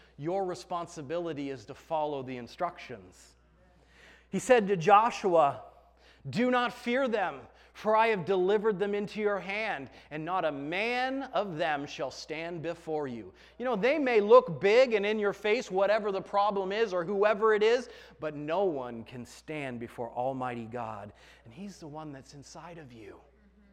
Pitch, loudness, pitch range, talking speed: 175 Hz, -29 LUFS, 135-210 Hz, 170 wpm